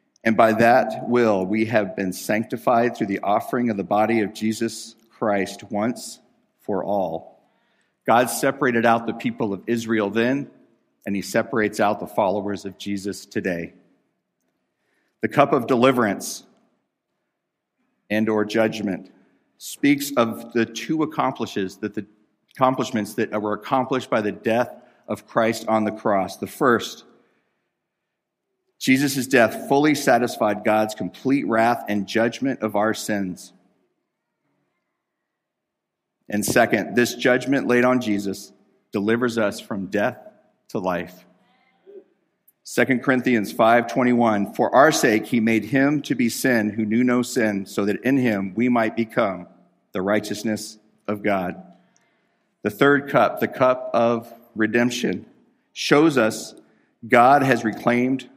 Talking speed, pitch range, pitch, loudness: 135 wpm, 105-125 Hz, 115 Hz, -21 LUFS